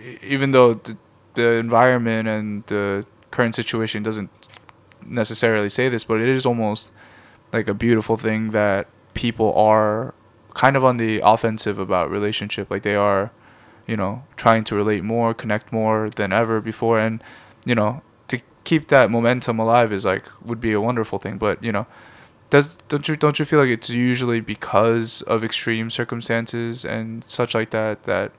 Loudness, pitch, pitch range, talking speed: -20 LUFS, 110 Hz, 105-120 Hz, 170 wpm